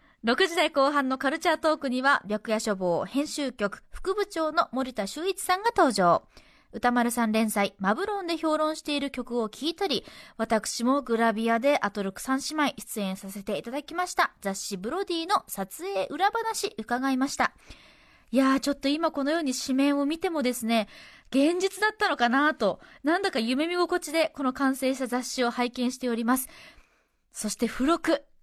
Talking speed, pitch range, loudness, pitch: 340 characters per minute, 230-320 Hz, -27 LUFS, 270 Hz